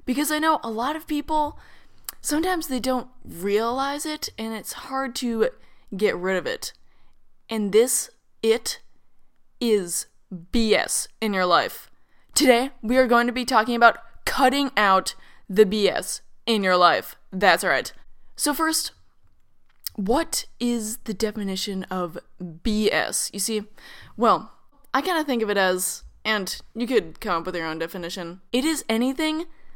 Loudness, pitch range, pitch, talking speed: -23 LUFS, 200-270 Hz, 230 Hz, 150 wpm